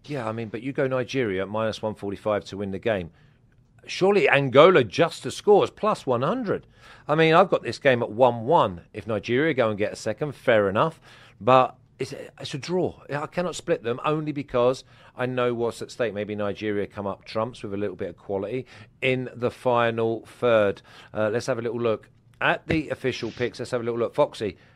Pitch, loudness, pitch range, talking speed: 125 Hz, -24 LUFS, 110-135 Hz, 210 wpm